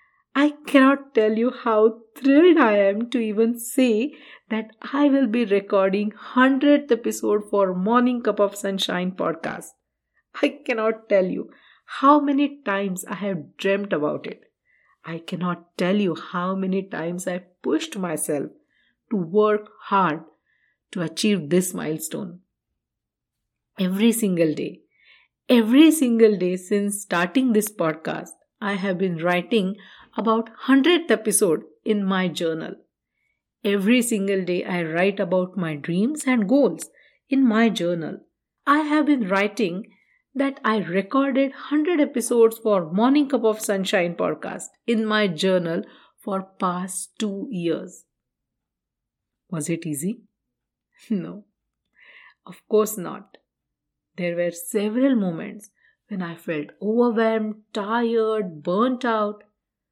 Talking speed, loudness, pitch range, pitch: 125 wpm, -22 LUFS, 185-245 Hz, 210 Hz